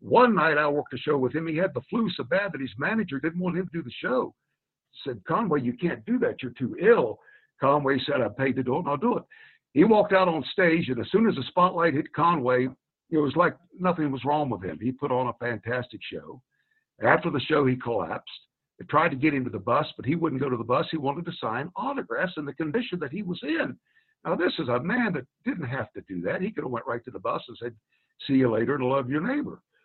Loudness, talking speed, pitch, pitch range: -26 LUFS, 265 wpm, 150 Hz, 130-185 Hz